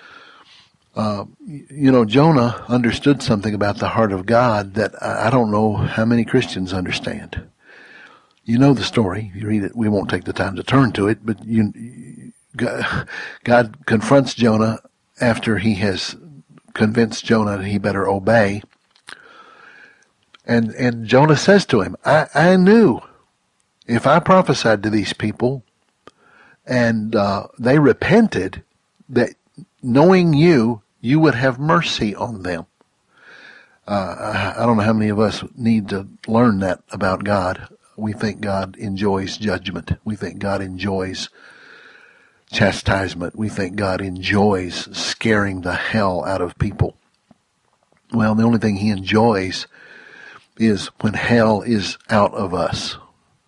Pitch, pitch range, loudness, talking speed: 110 Hz, 100-120 Hz, -18 LUFS, 140 wpm